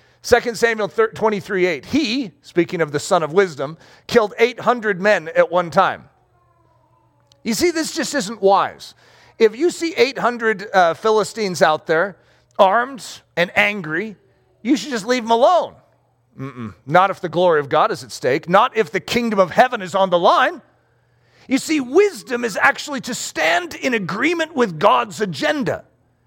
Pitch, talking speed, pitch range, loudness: 210 Hz, 165 wpm, 180-245 Hz, -18 LUFS